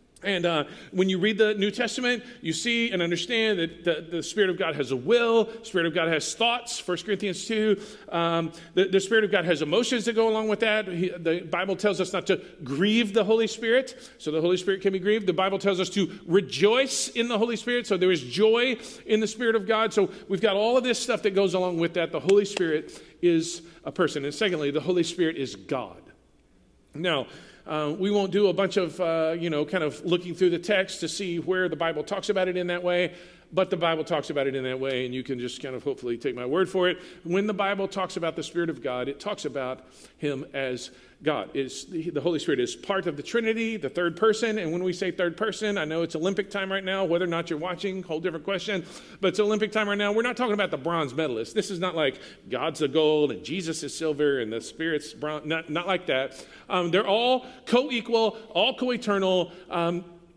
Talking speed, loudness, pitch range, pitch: 240 wpm, -26 LUFS, 165-210 Hz, 185 Hz